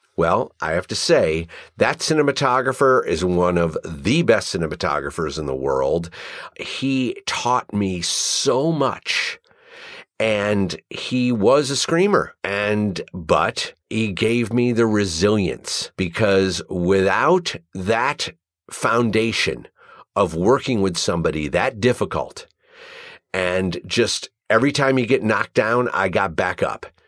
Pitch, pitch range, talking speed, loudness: 110 Hz, 95-130 Hz, 120 wpm, -20 LUFS